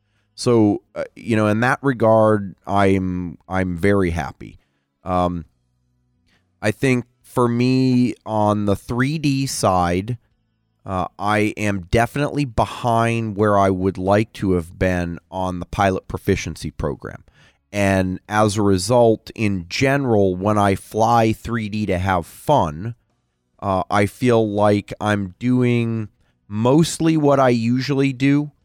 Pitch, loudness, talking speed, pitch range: 105 Hz, -19 LUFS, 130 wpm, 95-120 Hz